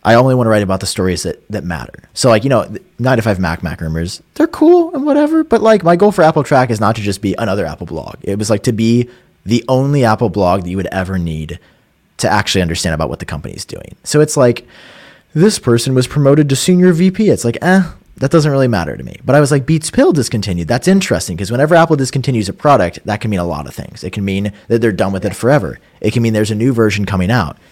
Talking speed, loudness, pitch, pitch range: 260 wpm, -13 LUFS, 115 Hz, 95-150 Hz